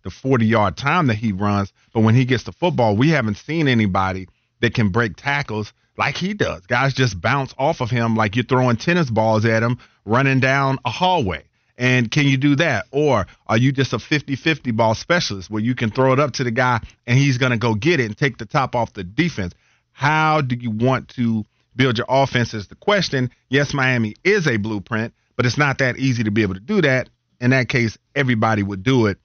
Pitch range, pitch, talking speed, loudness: 110-135 Hz, 125 Hz, 225 wpm, -19 LUFS